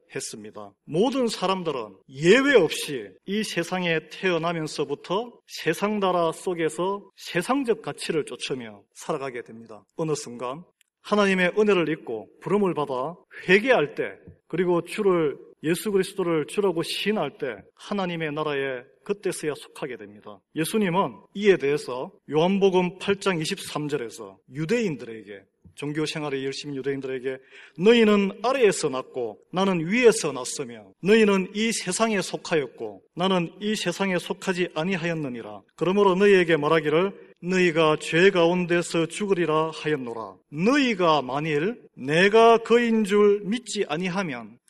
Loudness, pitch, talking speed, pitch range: -24 LUFS, 175 Hz, 310 characters per minute, 150-200 Hz